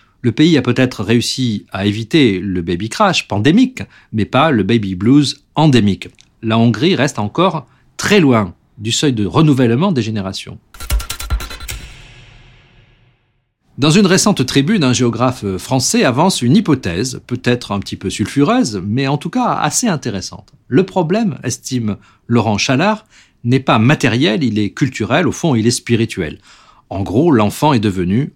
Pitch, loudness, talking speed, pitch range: 120 Hz, -15 LUFS, 150 wpm, 105-140 Hz